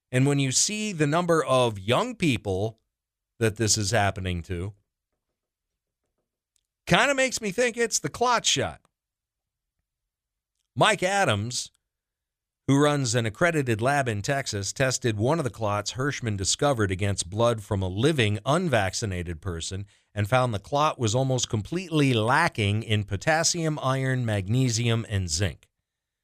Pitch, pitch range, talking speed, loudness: 120 Hz, 100-145 Hz, 135 wpm, -25 LUFS